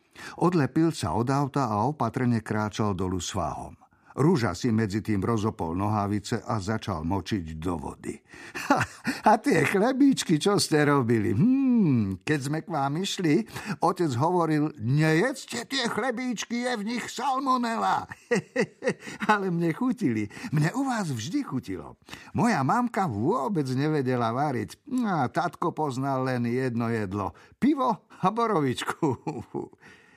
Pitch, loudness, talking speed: 145 Hz, -26 LUFS, 130 wpm